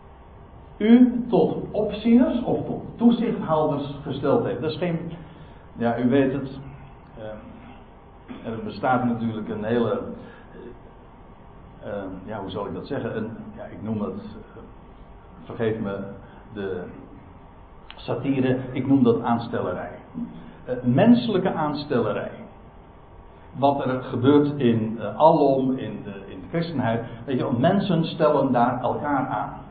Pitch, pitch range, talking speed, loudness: 135 Hz, 120-165 Hz, 130 wpm, -23 LUFS